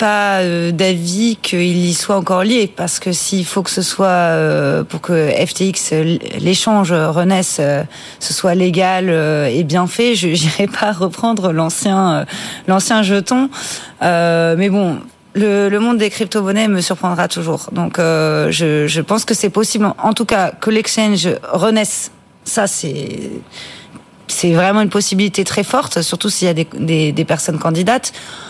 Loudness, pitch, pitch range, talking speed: -15 LUFS, 185 Hz, 170-210 Hz, 160 wpm